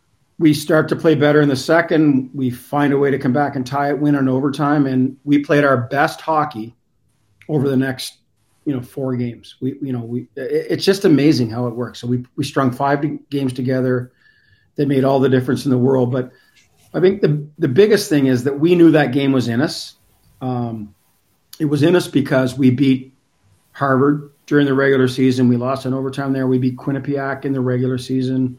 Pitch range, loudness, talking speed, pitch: 125-145 Hz, -17 LUFS, 210 wpm, 135 Hz